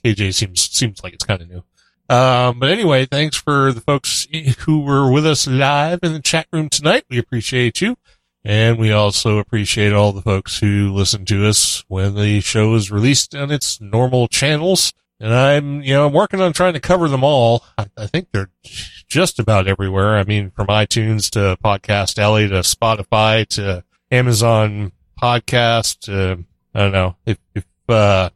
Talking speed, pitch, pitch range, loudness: 180 wpm, 110 Hz, 100-140 Hz, -16 LUFS